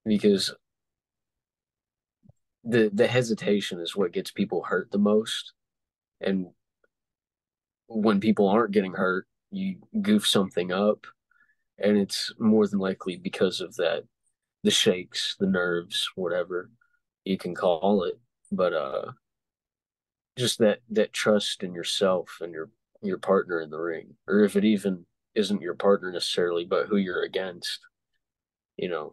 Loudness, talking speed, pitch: -26 LUFS, 140 wpm, 110 Hz